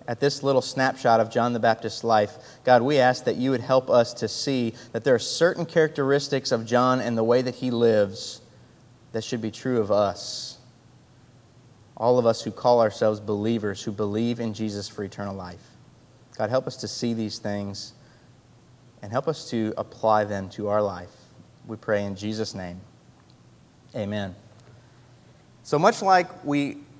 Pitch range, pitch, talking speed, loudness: 105-125 Hz, 120 Hz, 175 wpm, -24 LUFS